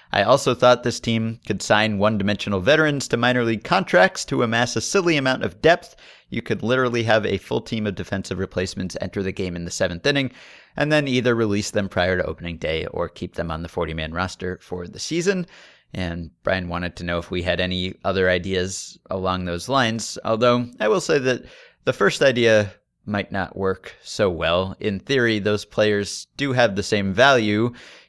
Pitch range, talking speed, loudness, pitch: 95-120 Hz, 200 wpm, -21 LUFS, 105 Hz